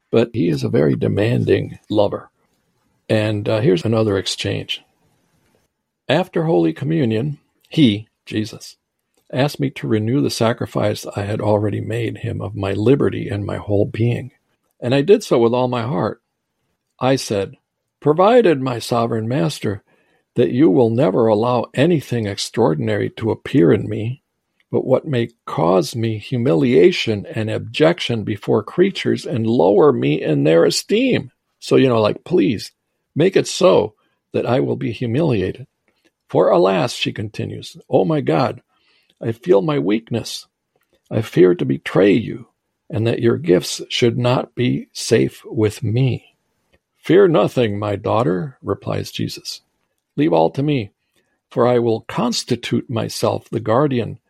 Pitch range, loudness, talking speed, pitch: 110-140 Hz, -18 LUFS, 145 wpm, 120 Hz